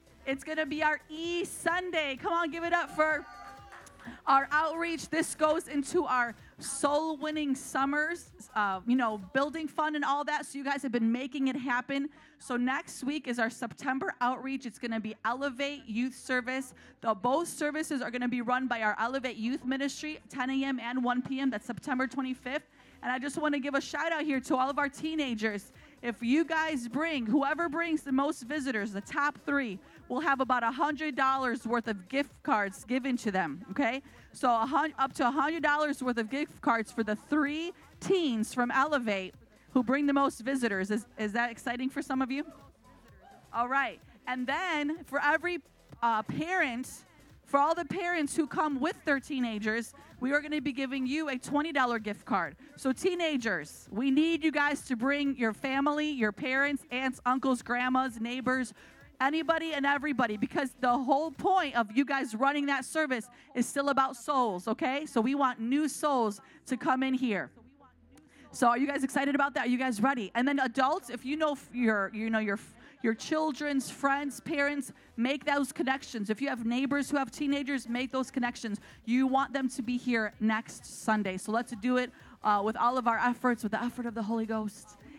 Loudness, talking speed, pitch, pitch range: -31 LUFS, 190 wpm, 270 Hz, 245-290 Hz